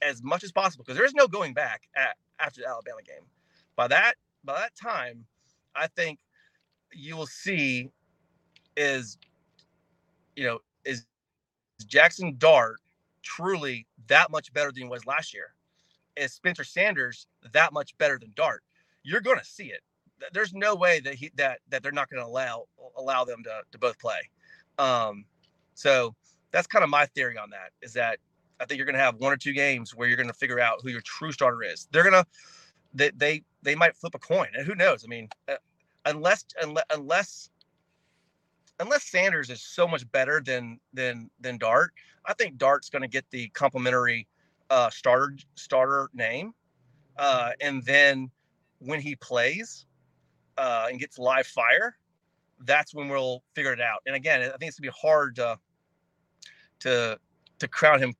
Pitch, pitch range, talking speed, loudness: 140 Hz, 125-155 Hz, 175 wpm, -25 LUFS